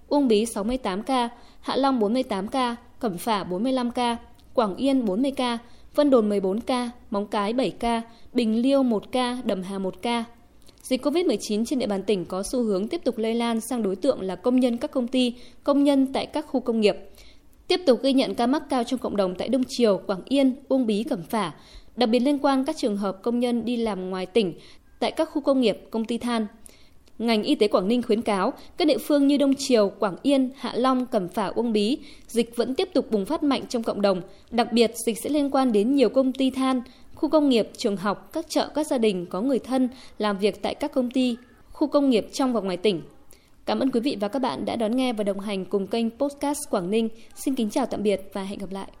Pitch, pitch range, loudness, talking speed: 240 Hz, 215-265 Hz, -24 LUFS, 240 wpm